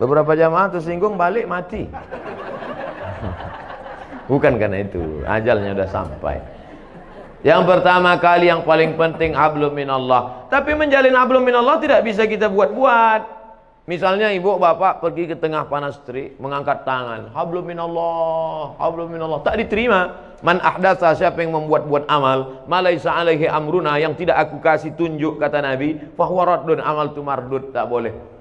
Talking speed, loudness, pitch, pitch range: 135 wpm, -18 LUFS, 160 Hz, 145-180 Hz